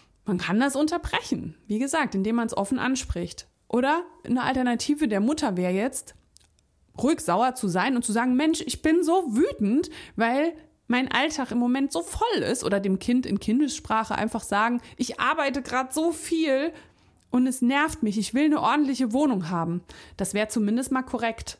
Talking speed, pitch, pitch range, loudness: 180 wpm, 250 Hz, 210-295 Hz, -25 LUFS